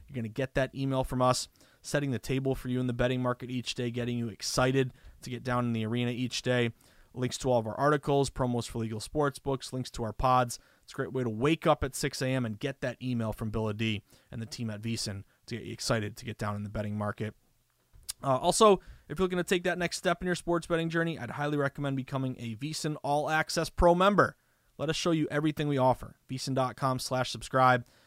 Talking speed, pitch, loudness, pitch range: 240 wpm, 130 Hz, -30 LUFS, 120-145 Hz